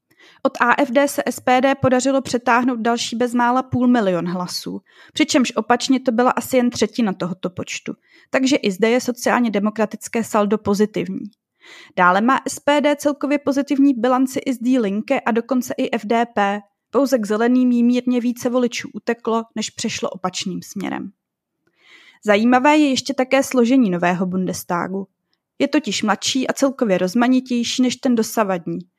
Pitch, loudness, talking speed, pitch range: 240 Hz, -19 LUFS, 145 wpm, 210-260 Hz